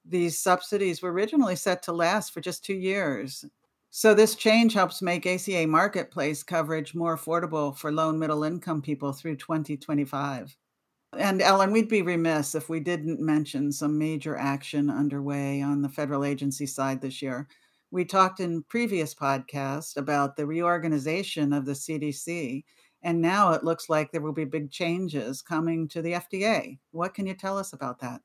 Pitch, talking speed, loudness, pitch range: 160 Hz, 170 wpm, -27 LUFS, 145-180 Hz